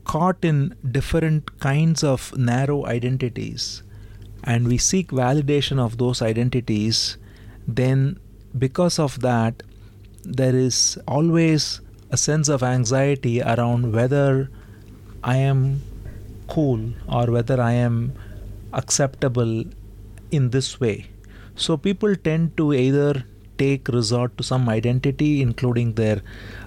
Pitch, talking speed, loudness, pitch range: 125 Hz, 110 wpm, -21 LUFS, 105-140 Hz